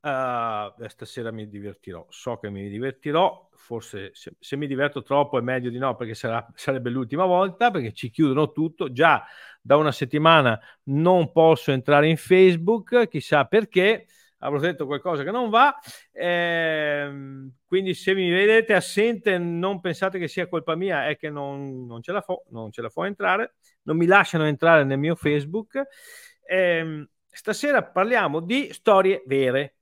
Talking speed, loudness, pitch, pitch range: 170 wpm, -22 LUFS, 155 Hz, 135-185 Hz